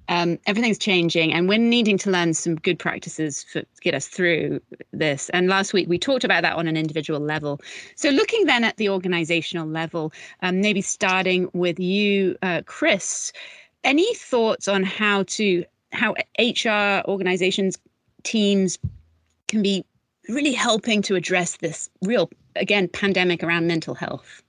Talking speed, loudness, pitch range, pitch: 155 wpm, -21 LUFS, 170-210 Hz, 185 Hz